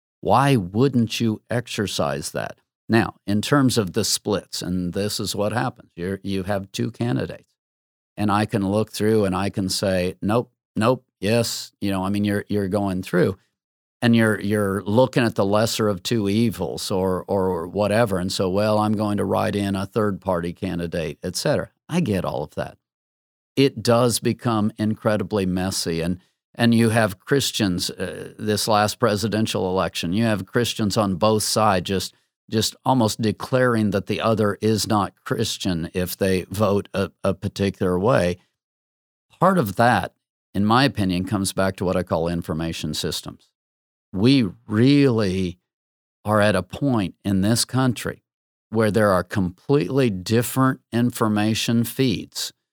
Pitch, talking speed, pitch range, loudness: 105 Hz, 160 wpm, 95-115 Hz, -22 LUFS